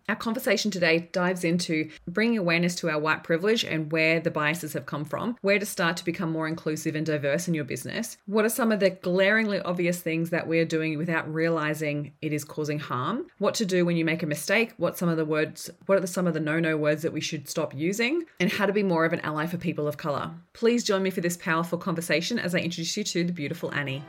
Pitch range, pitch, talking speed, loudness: 155-190 Hz, 170 Hz, 250 wpm, -26 LUFS